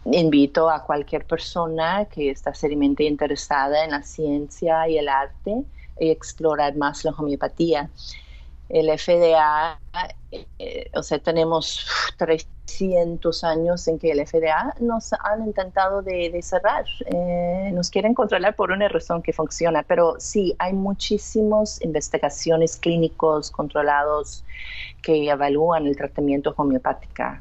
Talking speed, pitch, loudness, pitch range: 125 wpm, 160 Hz, -22 LUFS, 150-180 Hz